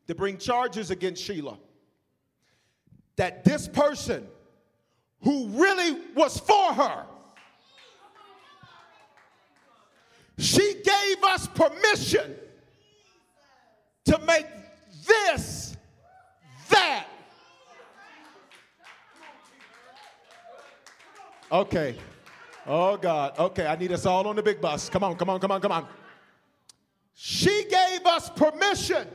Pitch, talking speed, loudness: 310 Hz, 95 wpm, -24 LUFS